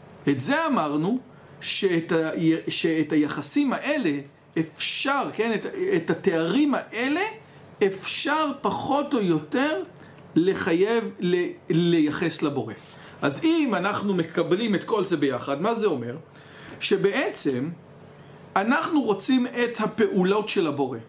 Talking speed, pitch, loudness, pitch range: 115 wpm, 195 Hz, -24 LUFS, 155-260 Hz